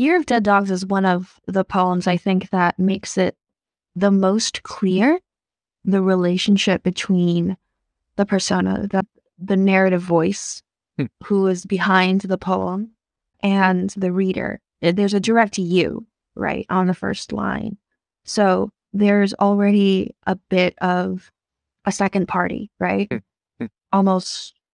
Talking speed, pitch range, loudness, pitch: 130 wpm, 185-200 Hz, -19 LUFS, 190 Hz